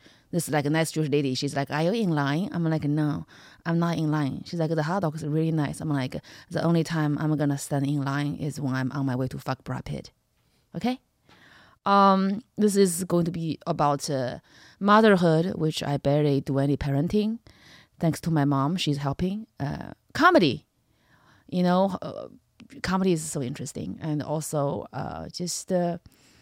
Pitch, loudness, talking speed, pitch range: 155 Hz, -26 LUFS, 190 wpm, 145-175 Hz